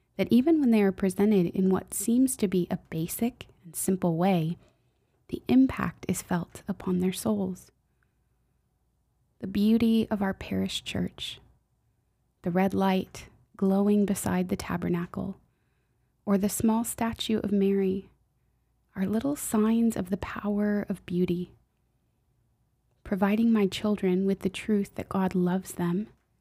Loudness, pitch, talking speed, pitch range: -27 LUFS, 195 Hz, 135 wpm, 180-210 Hz